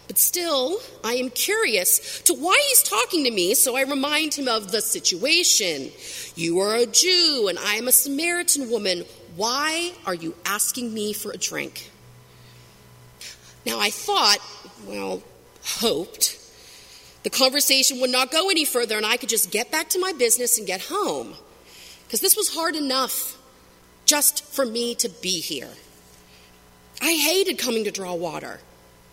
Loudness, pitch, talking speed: -20 LUFS, 245 Hz, 160 wpm